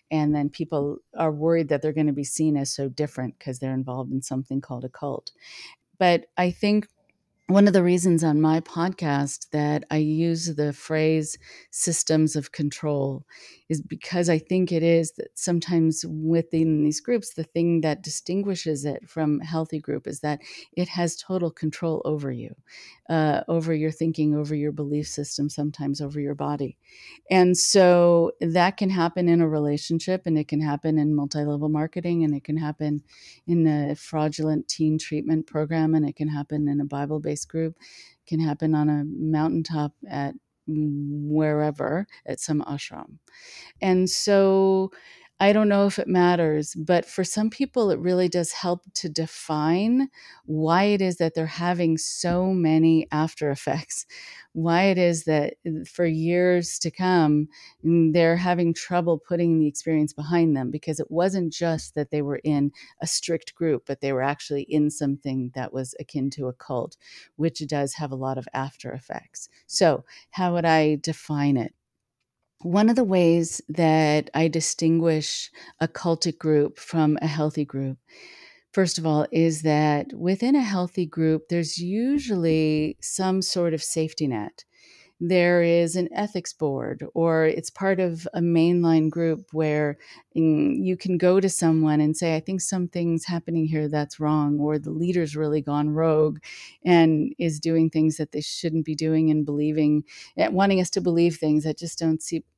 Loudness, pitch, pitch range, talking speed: -24 LUFS, 160 Hz, 150-175 Hz, 170 wpm